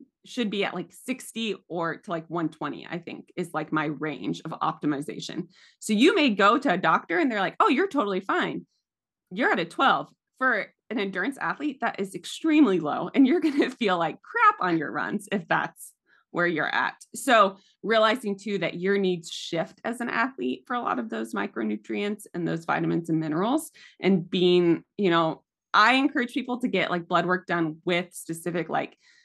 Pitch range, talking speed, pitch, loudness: 165-235 Hz, 195 wpm, 185 Hz, -25 LUFS